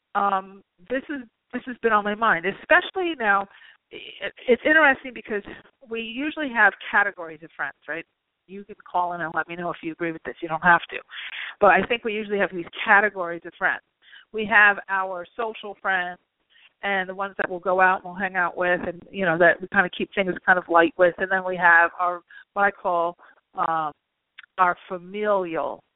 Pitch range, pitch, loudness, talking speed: 175-210 Hz, 190 Hz, -22 LUFS, 210 wpm